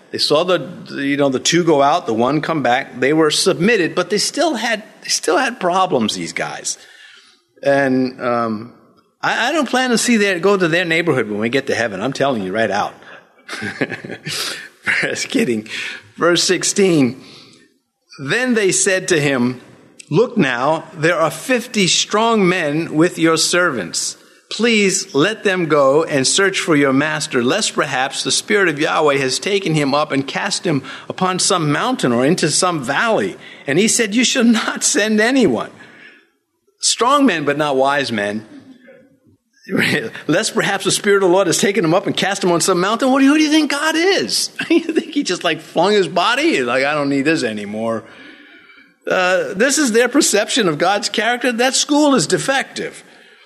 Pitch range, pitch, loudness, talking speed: 145-230 Hz, 180 Hz, -16 LUFS, 180 wpm